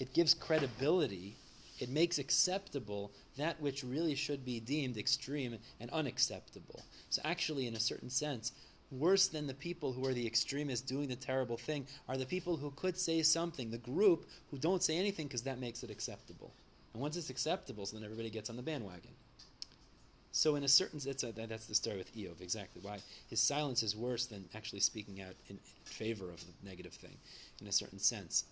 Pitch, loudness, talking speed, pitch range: 130 Hz, -37 LUFS, 195 wpm, 110-150 Hz